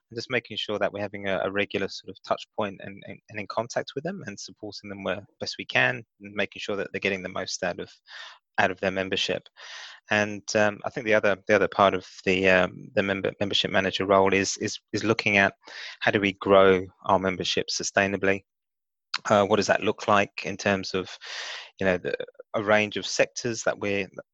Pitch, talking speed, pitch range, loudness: 100 Hz, 220 wpm, 95-105 Hz, -25 LUFS